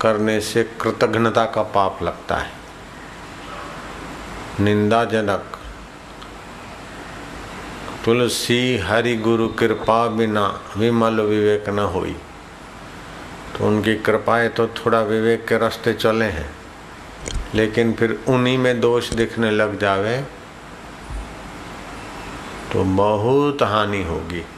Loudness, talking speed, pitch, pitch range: -19 LUFS, 95 wpm, 110 Hz, 105-115 Hz